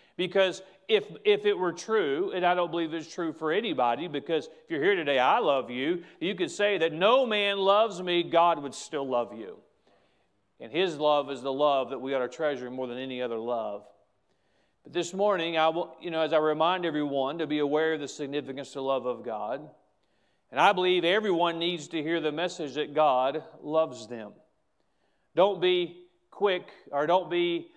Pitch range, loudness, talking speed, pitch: 145-185 Hz, -28 LUFS, 200 wpm, 165 Hz